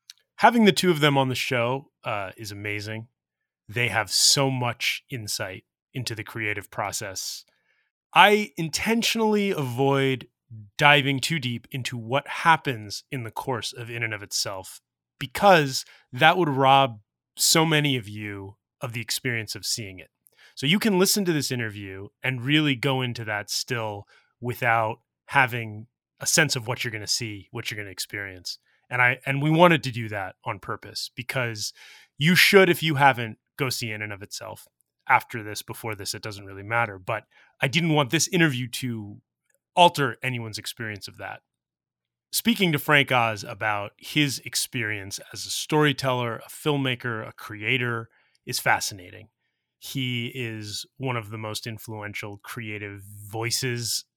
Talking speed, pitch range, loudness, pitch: 160 wpm, 105-140 Hz, -24 LUFS, 120 Hz